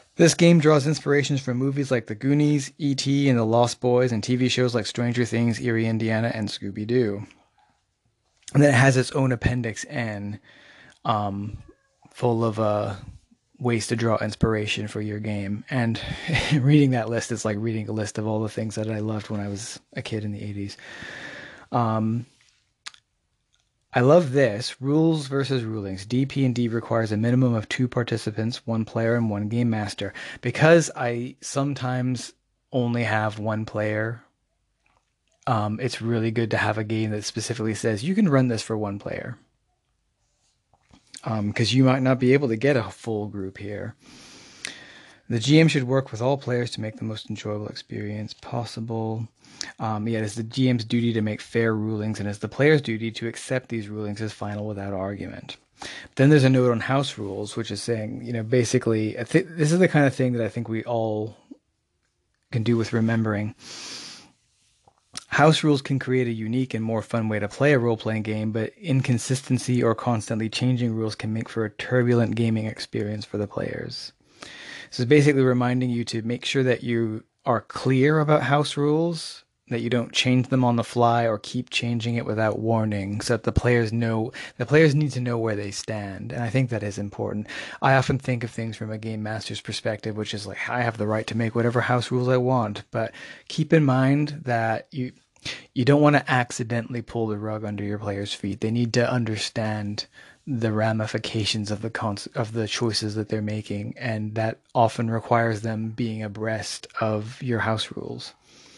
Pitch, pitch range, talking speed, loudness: 115 Hz, 110-125 Hz, 185 wpm, -24 LUFS